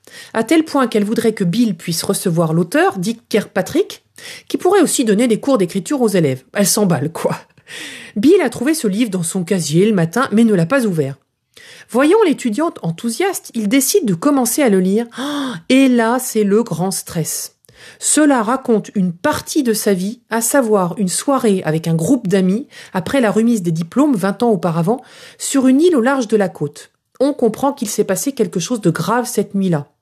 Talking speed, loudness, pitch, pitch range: 195 wpm, -16 LUFS, 225 Hz, 190-270 Hz